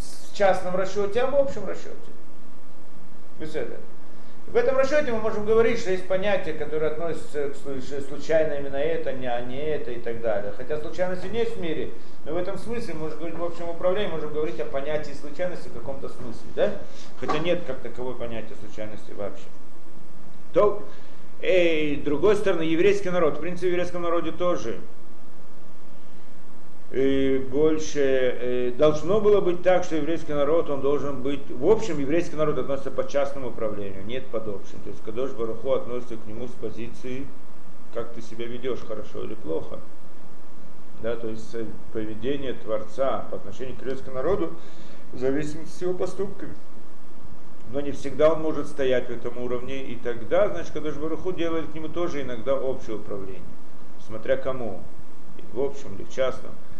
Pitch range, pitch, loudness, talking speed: 125-175 Hz, 145 Hz, -27 LUFS, 165 wpm